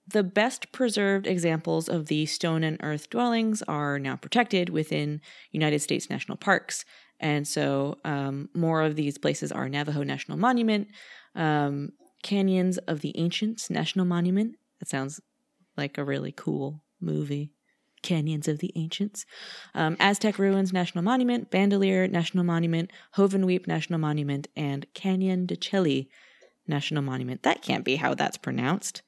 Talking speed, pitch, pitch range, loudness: 145 wpm, 170 Hz, 150-195 Hz, -27 LUFS